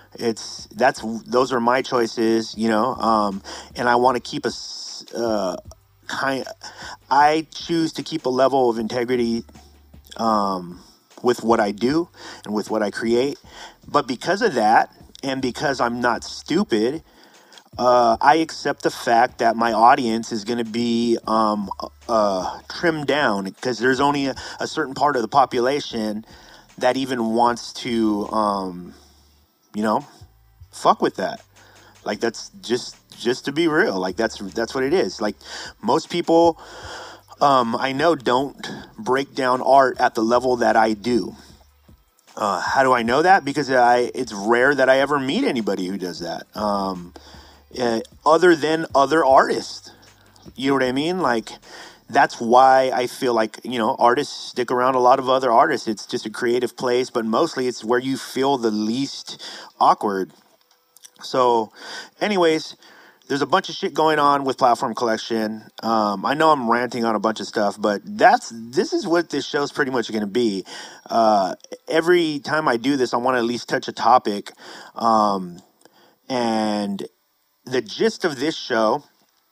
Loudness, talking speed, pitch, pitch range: -20 LUFS, 170 wpm, 120 Hz, 110-135 Hz